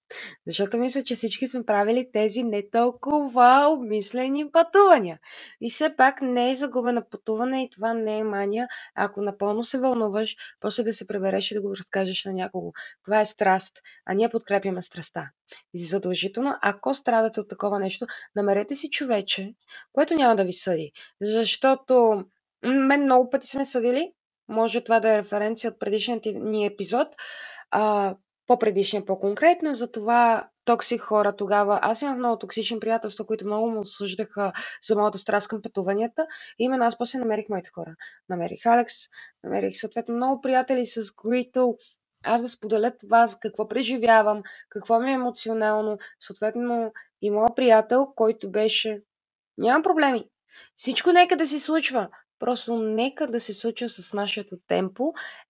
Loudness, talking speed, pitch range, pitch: -24 LUFS, 155 wpm, 205-250 Hz, 225 Hz